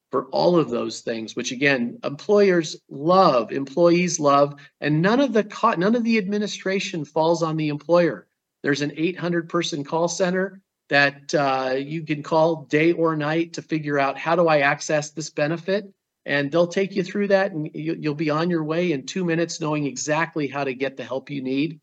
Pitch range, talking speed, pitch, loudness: 145-175 Hz, 195 wpm, 160 Hz, -22 LUFS